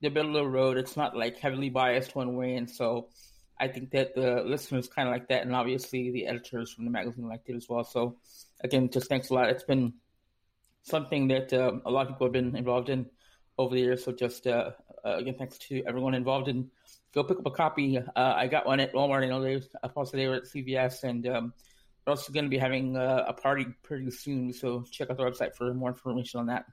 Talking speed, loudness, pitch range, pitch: 240 wpm, -30 LUFS, 125-135 Hz, 130 Hz